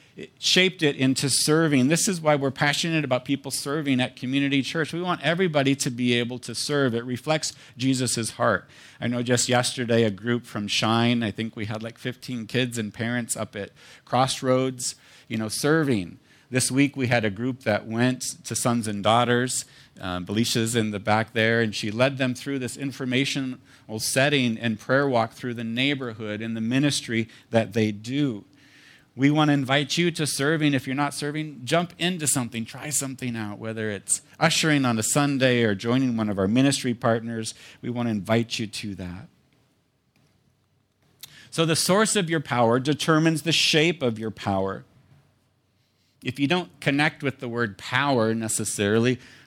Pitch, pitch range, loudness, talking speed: 125 Hz, 115-140 Hz, -24 LUFS, 180 wpm